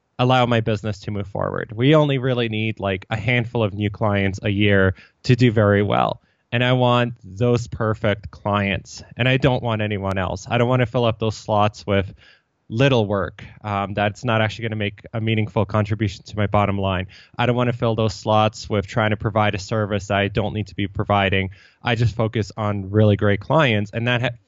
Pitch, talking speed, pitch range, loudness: 110 Hz, 215 wpm, 100-120 Hz, -21 LUFS